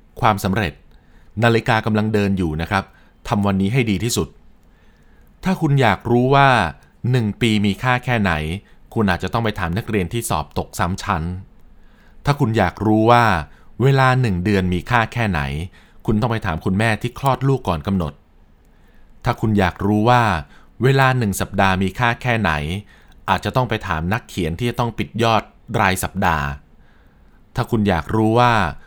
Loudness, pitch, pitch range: -19 LUFS, 105 Hz, 90-115 Hz